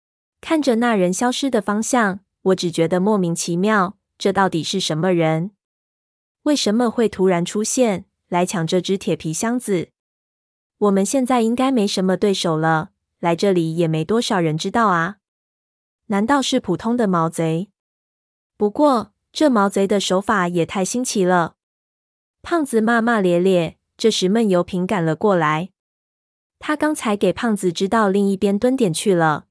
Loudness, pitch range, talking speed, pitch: -19 LUFS, 175-225 Hz, 230 characters per minute, 195 Hz